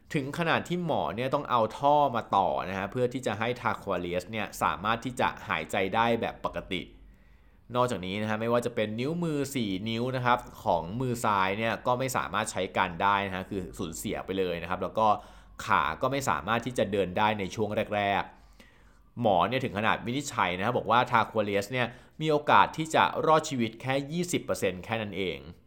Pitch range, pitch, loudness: 100-130 Hz, 115 Hz, -29 LUFS